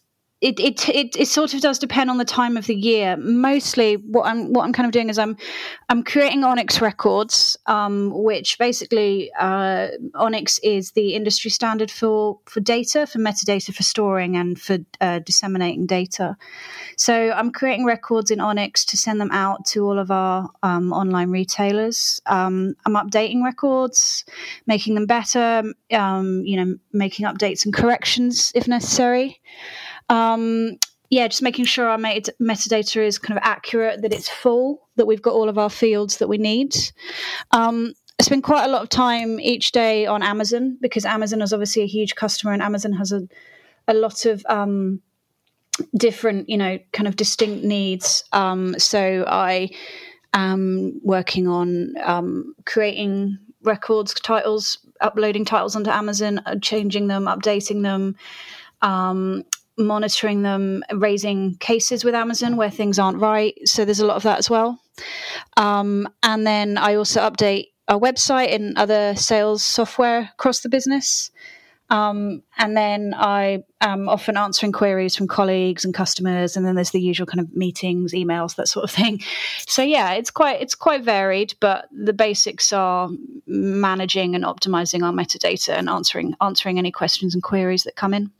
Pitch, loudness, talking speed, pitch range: 215 Hz, -19 LUFS, 165 wpm, 195-235 Hz